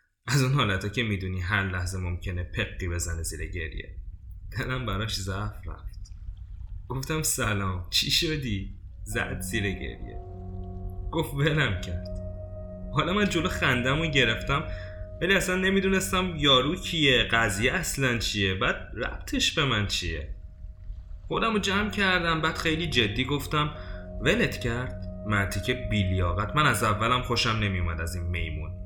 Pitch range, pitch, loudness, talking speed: 90-130 Hz, 100 Hz, -26 LUFS, 135 wpm